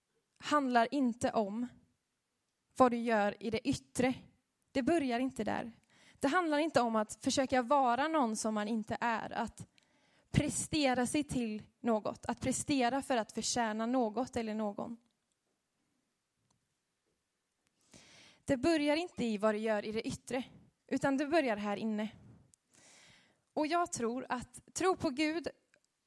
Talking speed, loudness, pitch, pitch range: 140 wpm, -34 LUFS, 245 Hz, 225-280 Hz